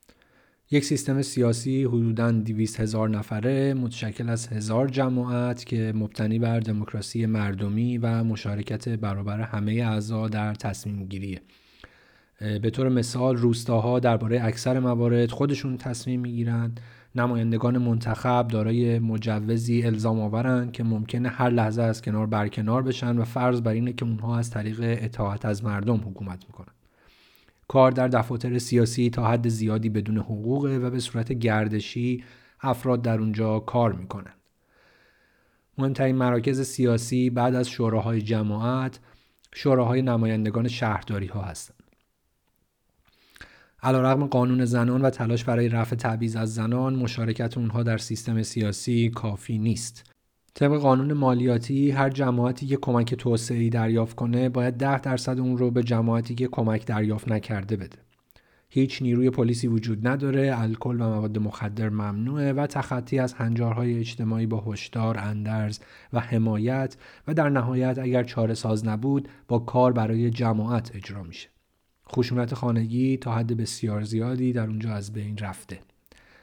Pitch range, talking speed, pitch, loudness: 110-125 Hz, 135 wpm, 115 Hz, -25 LUFS